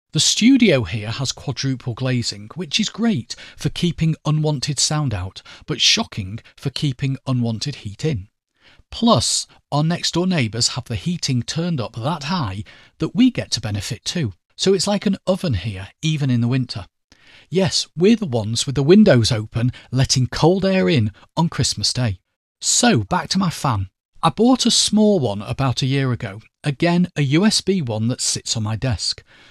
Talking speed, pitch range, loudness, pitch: 175 wpm, 115-170 Hz, -19 LUFS, 135 Hz